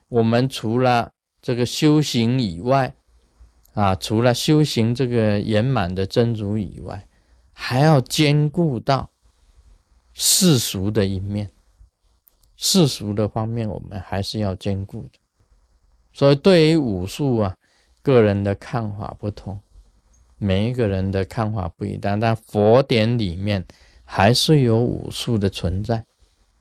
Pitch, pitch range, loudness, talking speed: 105 Hz, 95-120 Hz, -20 LUFS, 190 characters per minute